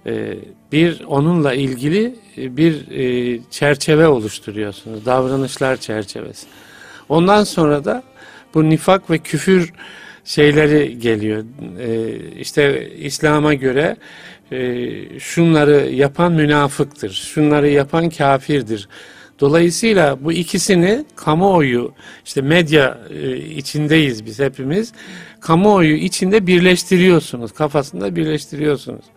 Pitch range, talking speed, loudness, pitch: 135-170 Hz, 80 wpm, -16 LUFS, 150 Hz